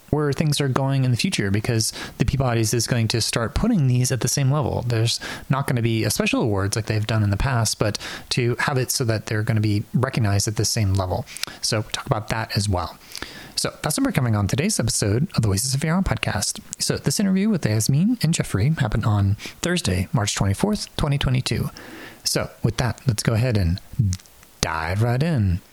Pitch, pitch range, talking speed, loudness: 120 Hz, 105-140 Hz, 215 wpm, -22 LUFS